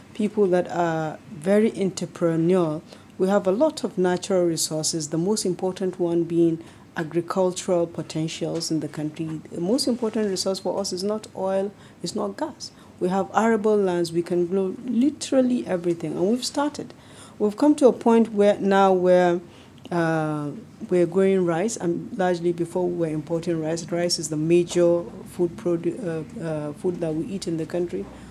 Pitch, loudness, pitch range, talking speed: 180 Hz, -23 LUFS, 165-200 Hz, 170 wpm